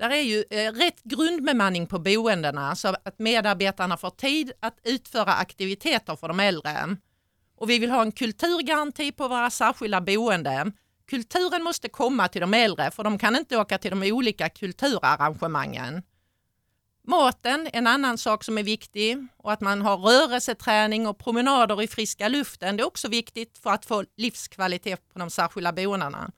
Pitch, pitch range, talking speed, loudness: 215 Hz, 195-245 Hz, 165 wpm, -24 LUFS